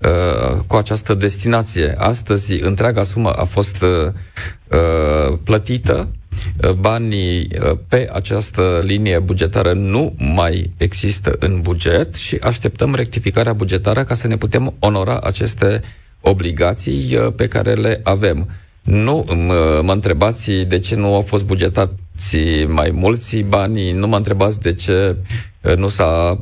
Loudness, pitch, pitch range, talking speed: -16 LUFS, 95 Hz, 90-105 Hz, 135 wpm